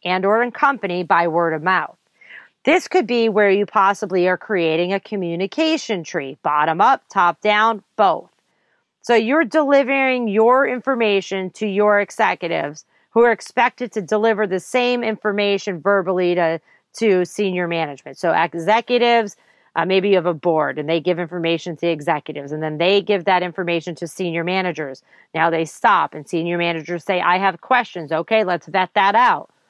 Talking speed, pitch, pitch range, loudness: 170 wpm, 190 Hz, 170-220 Hz, -18 LUFS